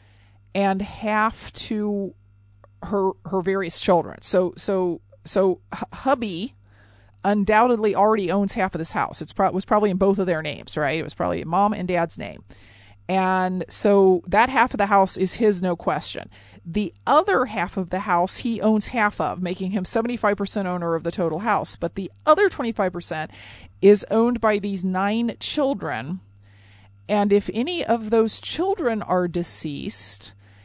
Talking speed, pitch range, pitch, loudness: 160 wpm, 165-210 Hz, 190 Hz, -22 LUFS